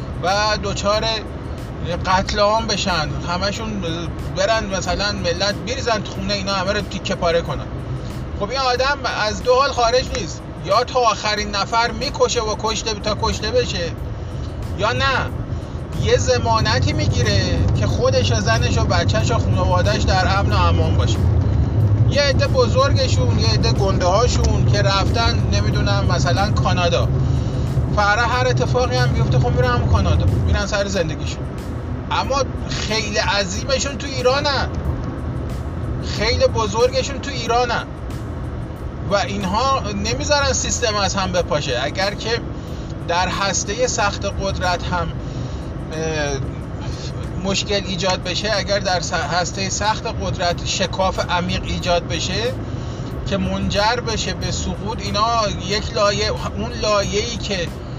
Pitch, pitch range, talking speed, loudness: 110 Hz, 100-130 Hz, 130 wpm, -19 LUFS